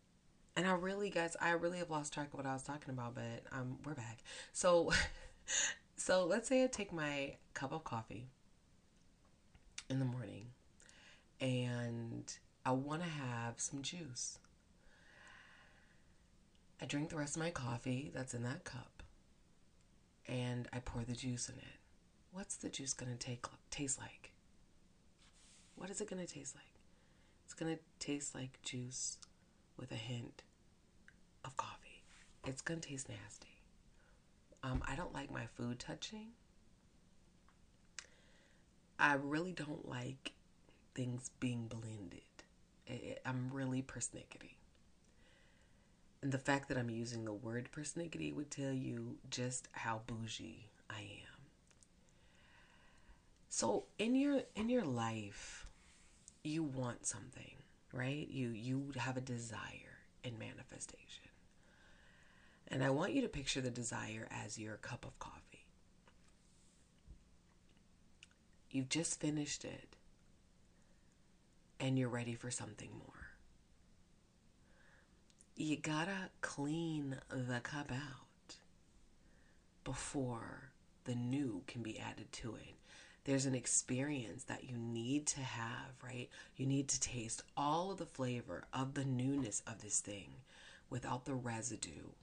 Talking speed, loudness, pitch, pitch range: 130 wpm, -42 LUFS, 130 Hz, 120-145 Hz